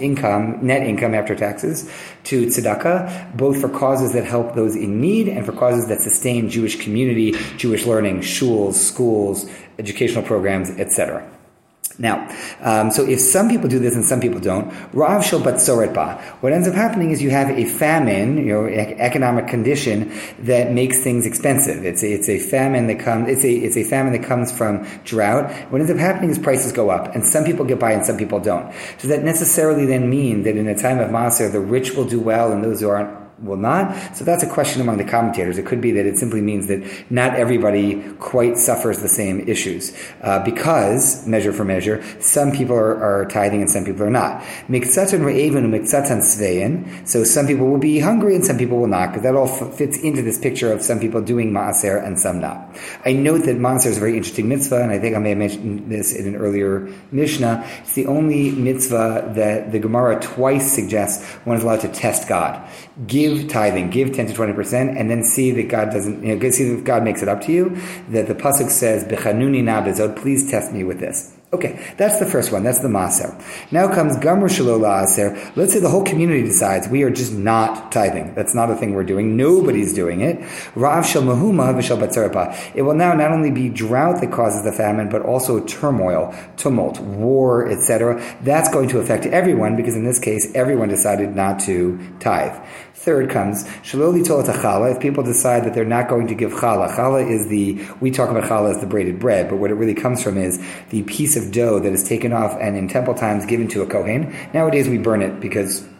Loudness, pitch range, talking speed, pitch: -18 LUFS, 105-135 Hz, 205 wpm, 115 Hz